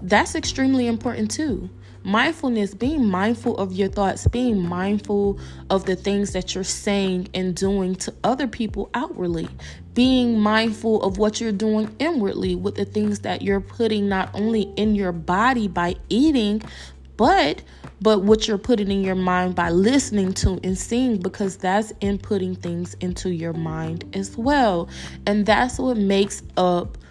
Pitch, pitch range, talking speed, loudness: 200 Hz, 185-220 Hz, 155 wpm, -22 LUFS